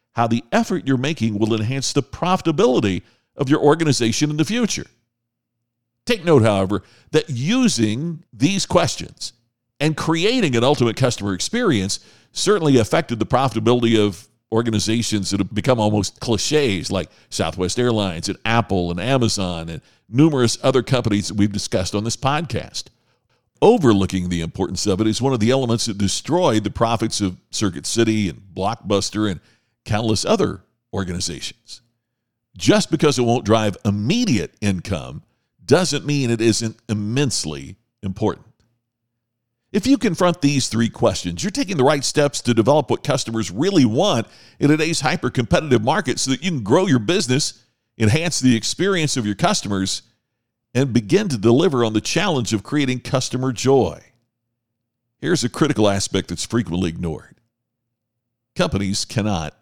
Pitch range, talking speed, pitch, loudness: 105-135 Hz, 150 wpm, 115 Hz, -19 LUFS